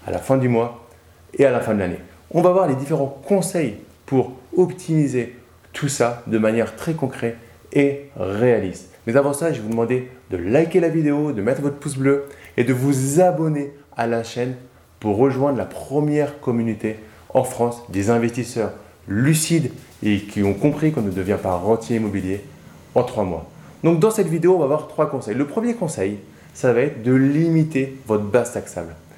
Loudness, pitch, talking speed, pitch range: -20 LUFS, 125 Hz, 190 wpm, 110-150 Hz